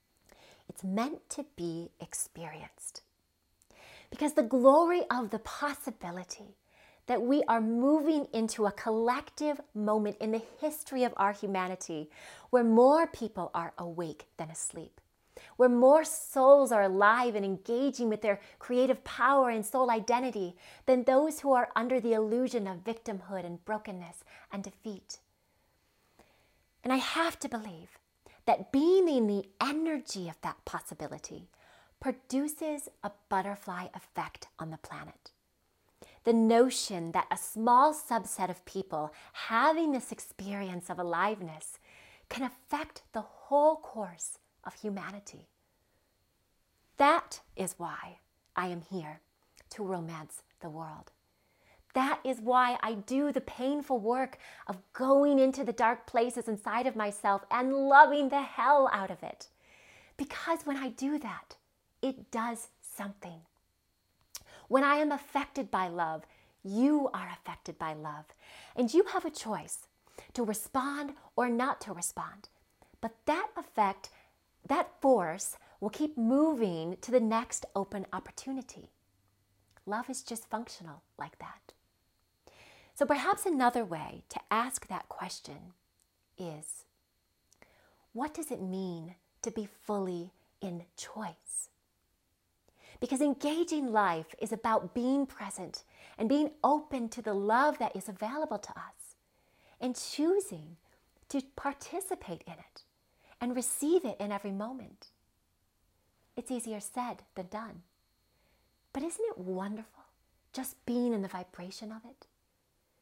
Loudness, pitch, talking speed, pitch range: -31 LUFS, 230 Hz, 130 wpm, 195-275 Hz